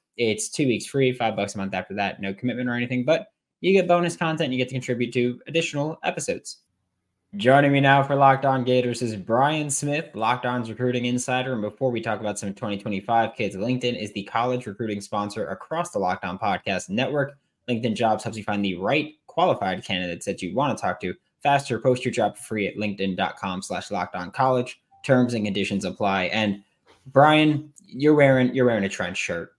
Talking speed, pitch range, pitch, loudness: 195 wpm, 105-140 Hz, 125 Hz, -24 LUFS